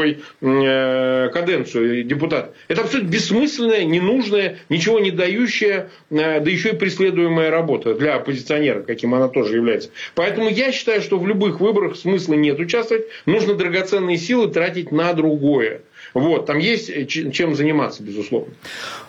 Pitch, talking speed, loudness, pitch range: 170 Hz, 130 wpm, -19 LUFS, 145-205 Hz